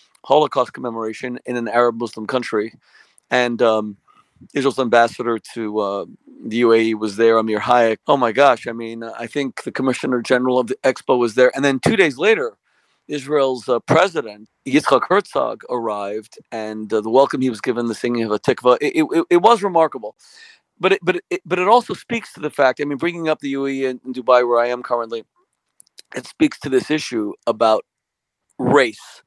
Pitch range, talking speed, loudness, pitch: 115-150 Hz, 190 wpm, -18 LUFS, 125 Hz